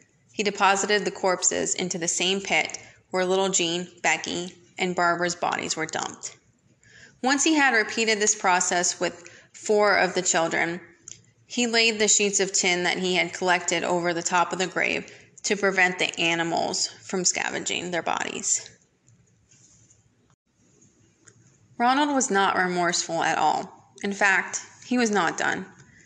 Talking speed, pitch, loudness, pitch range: 145 wpm, 185 Hz, -23 LUFS, 175-205 Hz